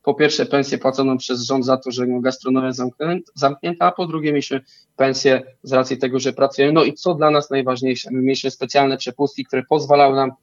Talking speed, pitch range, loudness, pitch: 195 wpm, 130-145 Hz, -19 LUFS, 135 Hz